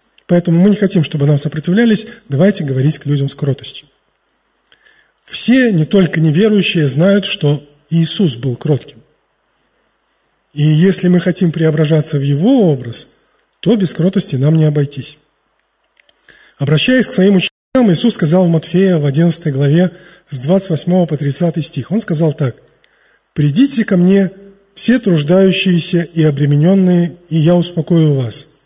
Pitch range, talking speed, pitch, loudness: 150-190 Hz, 140 wpm, 165 Hz, -13 LUFS